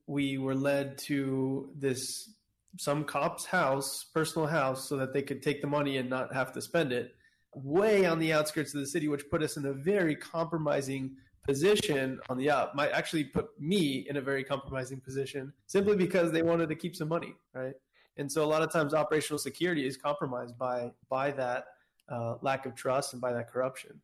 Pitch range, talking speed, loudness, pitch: 130-160 Hz, 200 wpm, -32 LUFS, 140 Hz